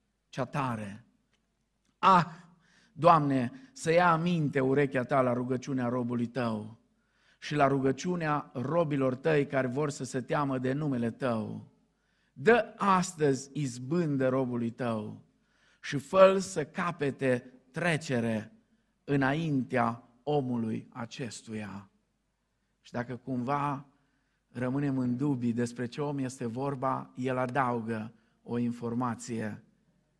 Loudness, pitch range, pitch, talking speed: -30 LUFS, 120-150 Hz, 135 Hz, 105 wpm